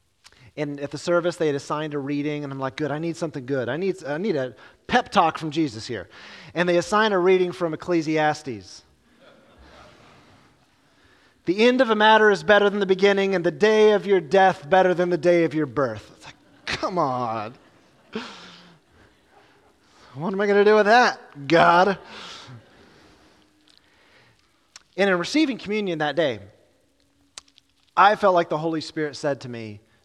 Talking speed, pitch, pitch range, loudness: 170 wpm, 175 Hz, 150-200 Hz, -21 LUFS